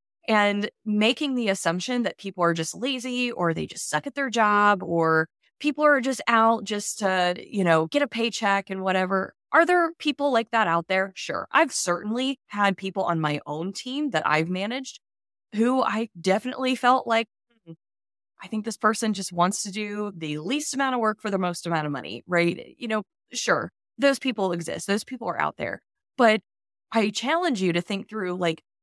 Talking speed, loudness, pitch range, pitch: 195 wpm, -25 LUFS, 180-250 Hz, 210 Hz